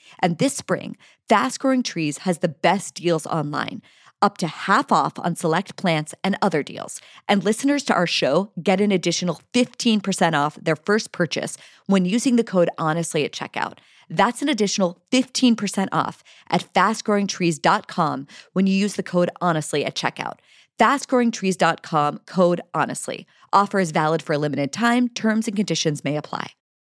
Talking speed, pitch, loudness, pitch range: 160 wpm, 185 Hz, -21 LUFS, 165-210 Hz